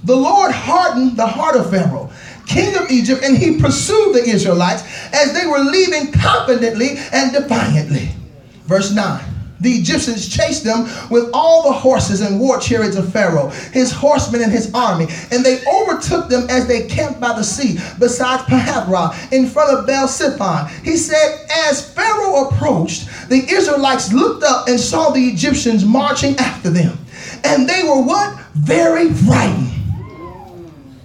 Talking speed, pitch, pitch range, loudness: 155 wpm, 250 Hz, 195-285 Hz, -14 LUFS